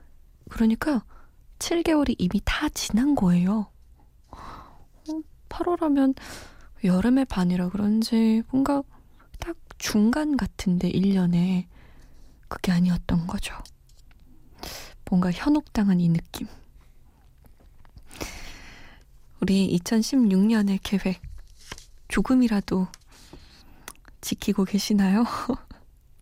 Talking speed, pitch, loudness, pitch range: 165 characters per minute, 200 Hz, -24 LUFS, 180-240 Hz